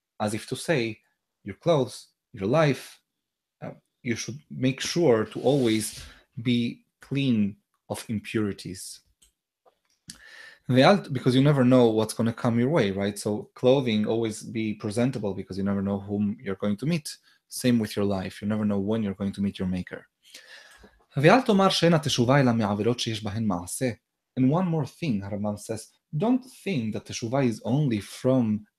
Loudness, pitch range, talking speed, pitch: -25 LUFS, 105-130 Hz, 150 wpm, 115 Hz